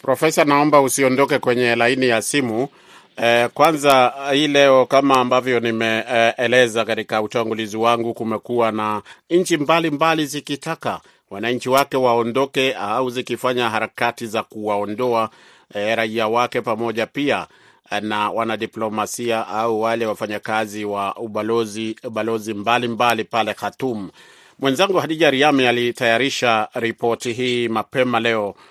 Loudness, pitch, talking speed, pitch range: -19 LUFS, 120 Hz, 115 wpm, 110-130 Hz